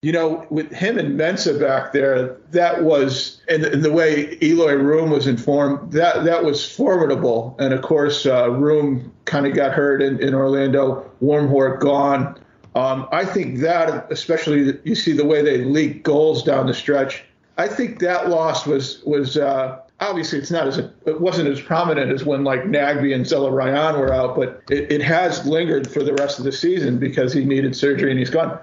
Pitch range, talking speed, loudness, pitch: 135-160 Hz, 195 wpm, -19 LUFS, 145 Hz